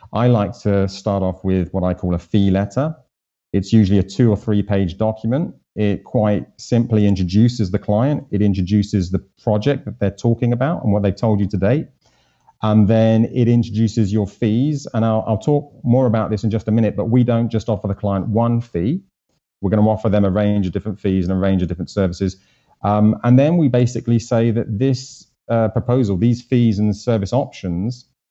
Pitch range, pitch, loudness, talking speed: 100-120 Hz, 110 Hz, -18 LUFS, 210 wpm